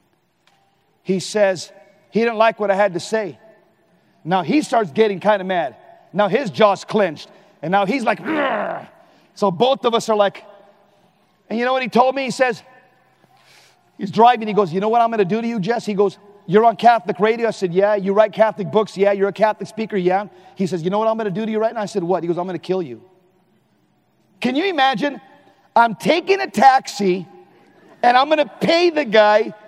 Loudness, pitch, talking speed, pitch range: -18 LUFS, 210 Hz, 215 wpm, 195-230 Hz